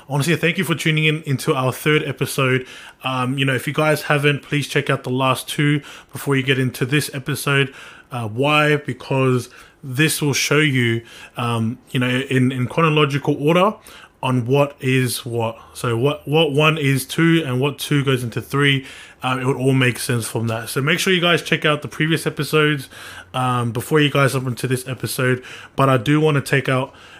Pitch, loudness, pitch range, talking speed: 140 Hz, -19 LUFS, 130-150 Hz, 205 wpm